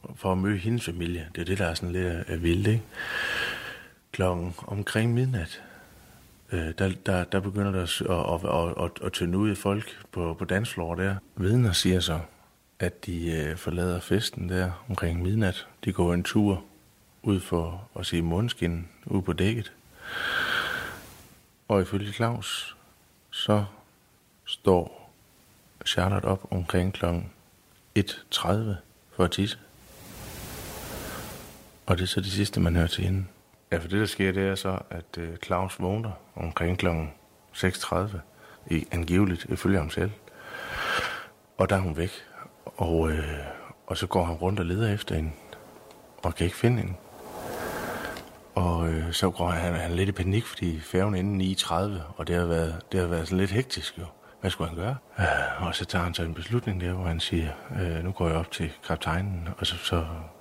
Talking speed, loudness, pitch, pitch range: 170 wpm, -28 LUFS, 90 Hz, 85-100 Hz